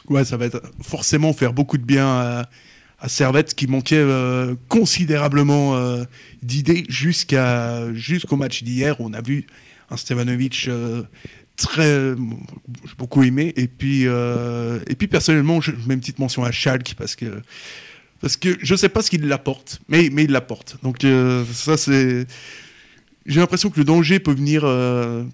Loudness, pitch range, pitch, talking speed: -19 LUFS, 125-150 Hz, 135 Hz, 175 wpm